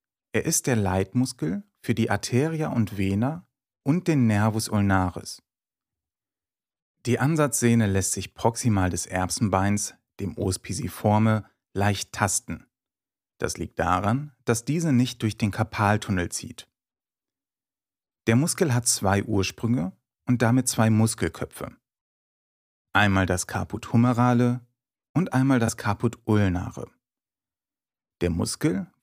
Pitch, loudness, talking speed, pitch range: 110 Hz, -24 LUFS, 110 wpm, 100-125 Hz